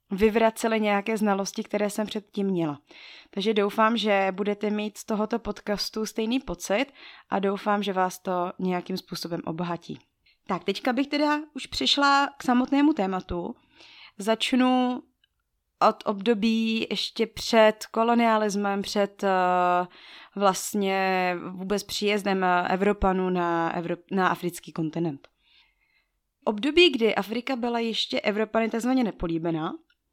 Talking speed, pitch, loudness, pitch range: 120 wpm, 210 Hz, -25 LUFS, 185-230 Hz